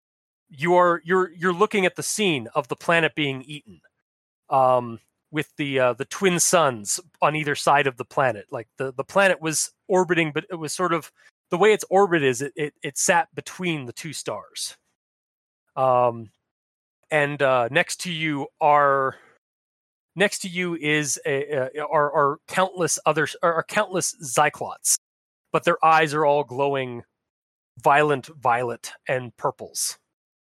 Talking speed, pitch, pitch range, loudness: 160 wpm, 150 Hz, 135-175 Hz, -22 LUFS